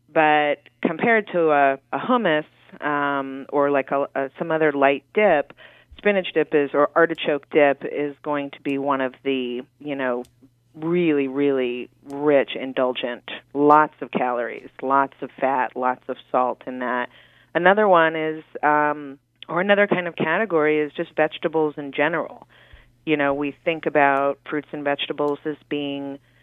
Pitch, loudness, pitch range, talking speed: 145 Hz, -22 LUFS, 135-155 Hz, 155 wpm